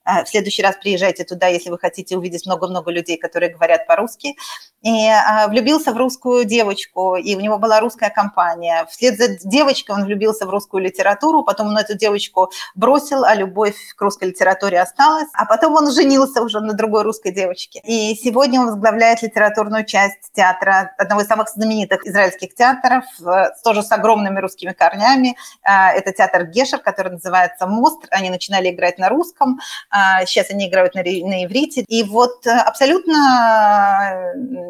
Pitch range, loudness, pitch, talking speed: 190-245 Hz, -16 LUFS, 210 Hz, 155 wpm